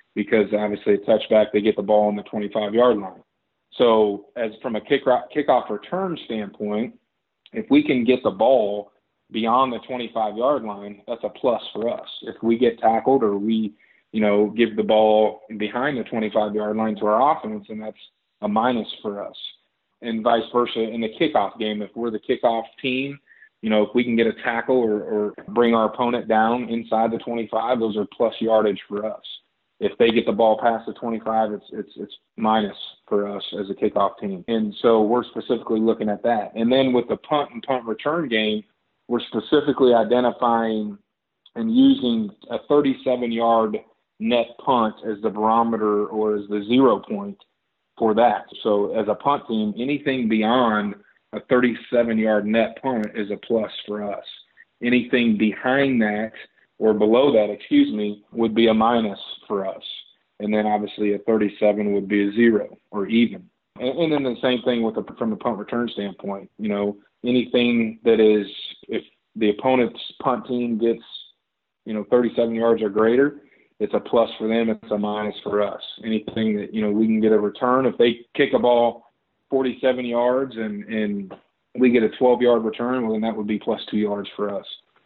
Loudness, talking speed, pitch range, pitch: -21 LUFS, 185 wpm, 105-120 Hz, 115 Hz